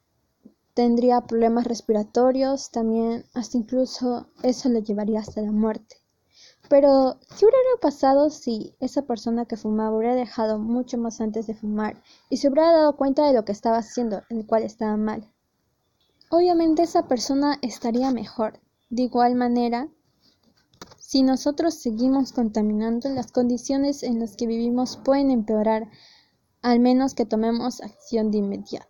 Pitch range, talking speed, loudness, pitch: 225-270 Hz, 145 wpm, -23 LUFS, 245 Hz